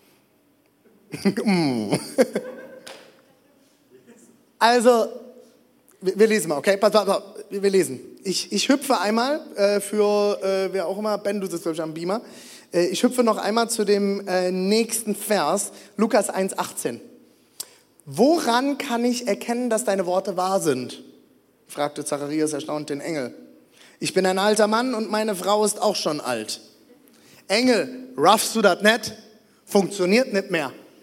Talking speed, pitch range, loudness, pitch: 145 wpm, 190-235 Hz, -22 LUFS, 205 Hz